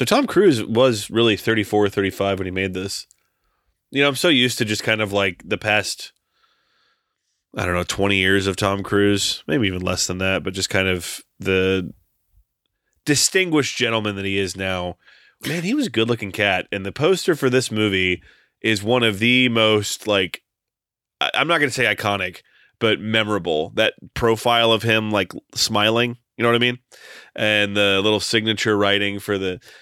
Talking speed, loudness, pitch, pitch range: 180 wpm, -19 LUFS, 105 Hz, 100-120 Hz